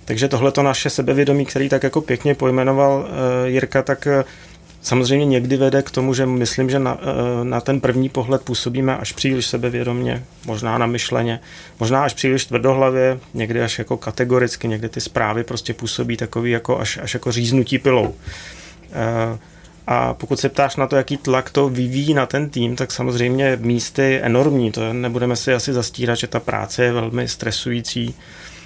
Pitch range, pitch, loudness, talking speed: 120-135 Hz, 125 Hz, -19 LUFS, 180 wpm